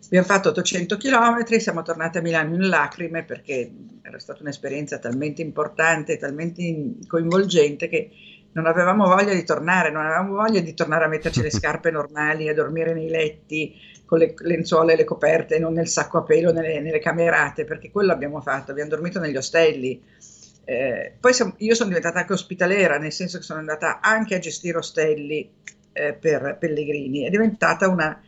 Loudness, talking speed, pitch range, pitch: -21 LUFS, 175 wpm, 155-185 Hz, 165 Hz